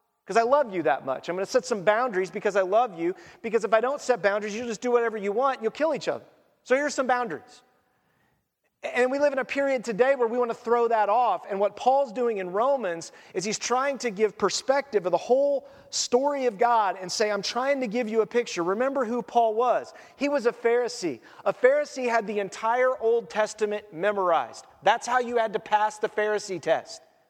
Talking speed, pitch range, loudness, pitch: 220 wpm, 210-255 Hz, -25 LUFS, 235 Hz